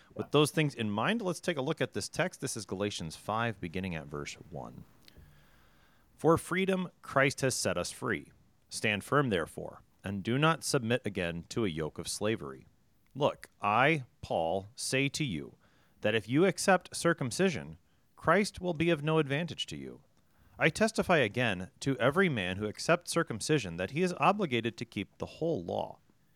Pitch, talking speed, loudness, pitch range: 125 Hz, 175 wpm, -31 LUFS, 95-160 Hz